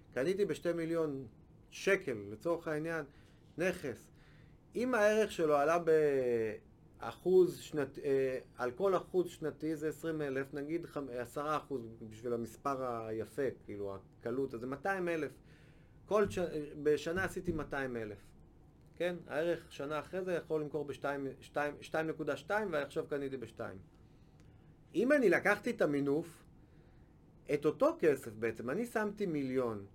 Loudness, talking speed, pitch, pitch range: -36 LUFS, 125 wpm, 150 Hz, 130-170 Hz